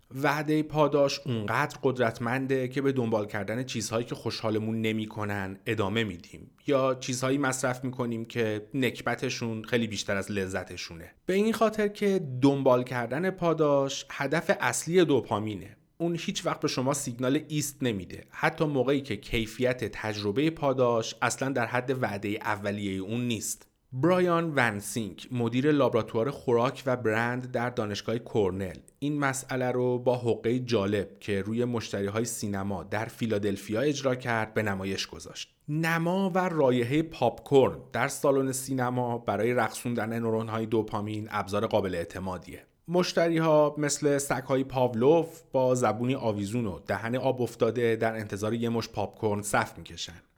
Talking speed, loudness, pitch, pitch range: 140 wpm, -28 LUFS, 120 Hz, 110-140 Hz